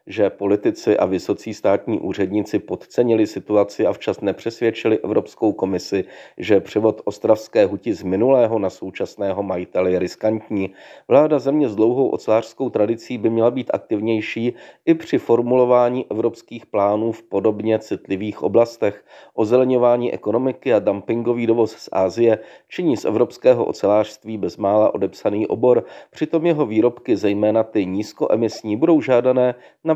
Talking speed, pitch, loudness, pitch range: 130 wpm, 115 Hz, -19 LUFS, 105-125 Hz